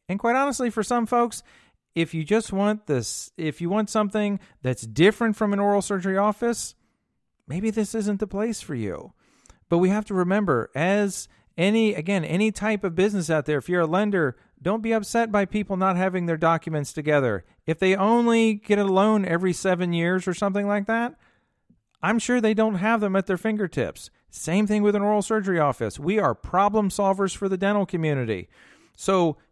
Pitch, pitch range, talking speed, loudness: 200 Hz, 175-215 Hz, 195 wpm, -24 LUFS